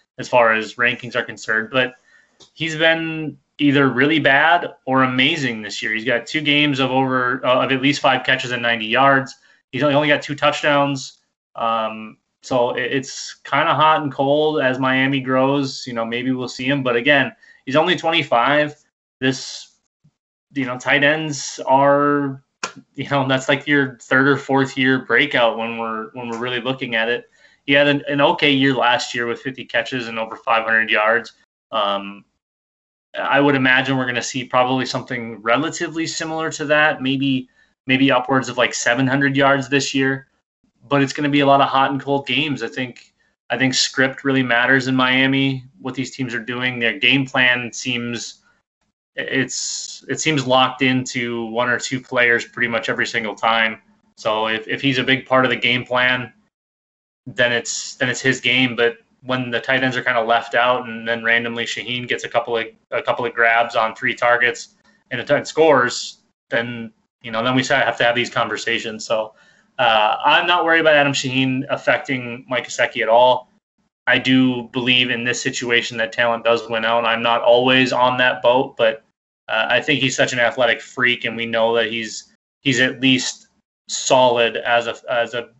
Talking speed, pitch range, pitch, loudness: 190 wpm, 120-140 Hz, 130 Hz, -18 LUFS